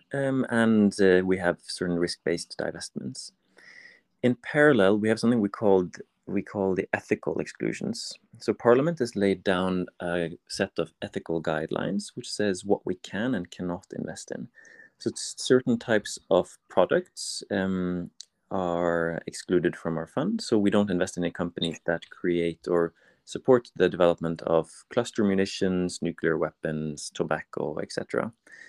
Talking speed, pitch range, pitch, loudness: 145 wpm, 85-105 Hz, 95 Hz, -27 LUFS